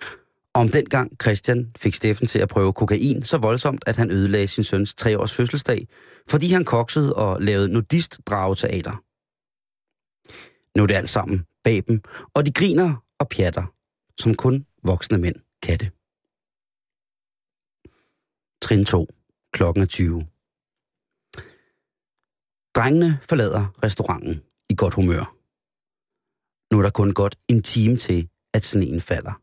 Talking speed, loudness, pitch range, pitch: 130 wpm, -21 LUFS, 95-125 Hz, 110 Hz